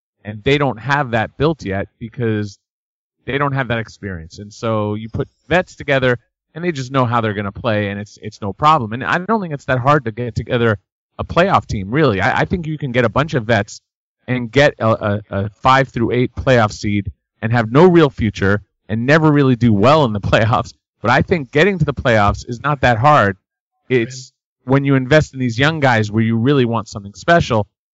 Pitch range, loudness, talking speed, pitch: 105-140 Hz, -16 LUFS, 225 wpm, 120 Hz